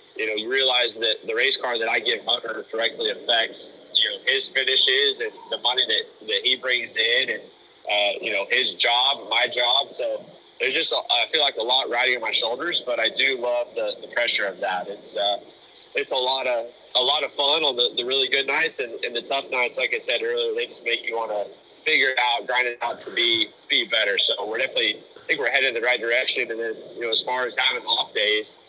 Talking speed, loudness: 245 wpm, -21 LUFS